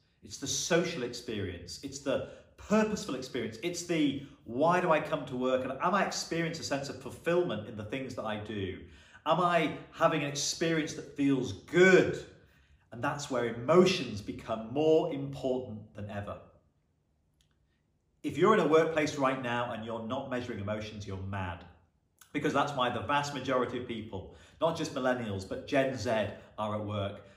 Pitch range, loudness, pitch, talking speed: 100-150 Hz, -31 LUFS, 125 Hz, 170 wpm